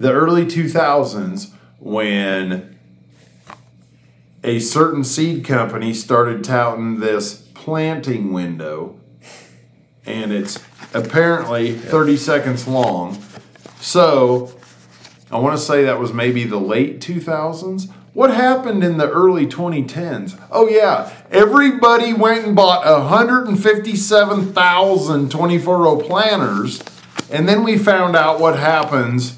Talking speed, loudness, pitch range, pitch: 110 wpm, -15 LUFS, 115-180 Hz, 145 Hz